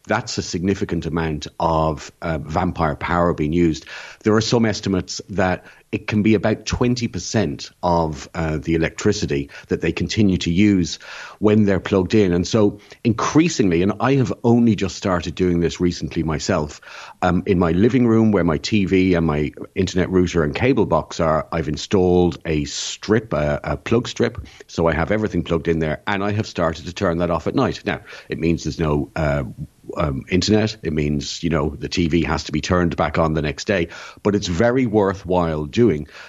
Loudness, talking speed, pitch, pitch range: -20 LUFS, 190 wpm, 90 Hz, 80-105 Hz